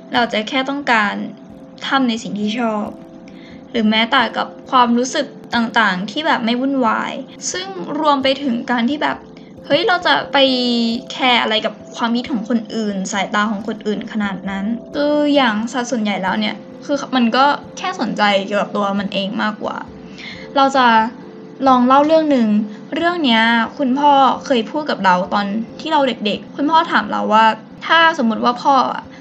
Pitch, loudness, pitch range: 240 Hz, -16 LUFS, 220-275 Hz